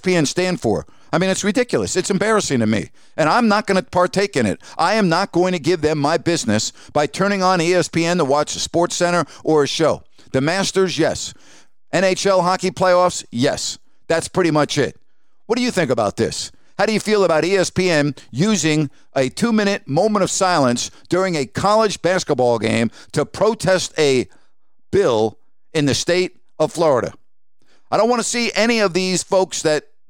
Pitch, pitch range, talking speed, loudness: 175 Hz, 150-190 Hz, 185 wpm, -18 LUFS